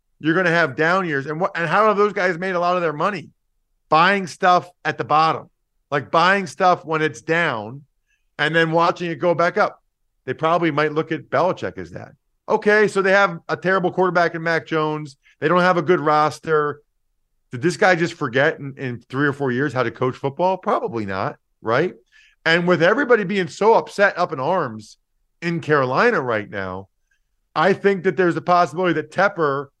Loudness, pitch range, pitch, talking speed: -19 LUFS, 145-185 Hz, 165 Hz, 200 wpm